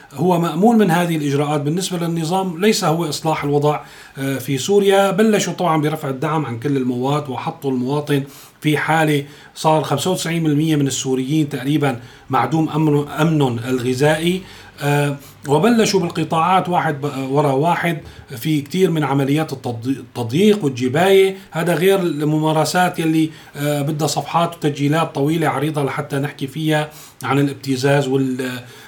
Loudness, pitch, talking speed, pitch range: -18 LUFS, 150 Hz, 125 wpm, 140-165 Hz